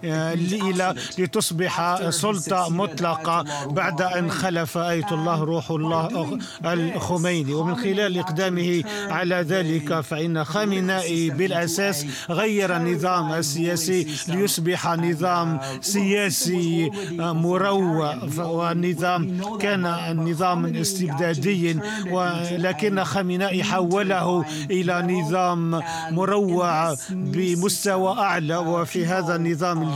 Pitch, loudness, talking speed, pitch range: 175 Hz, -23 LUFS, 80 wpm, 165-185 Hz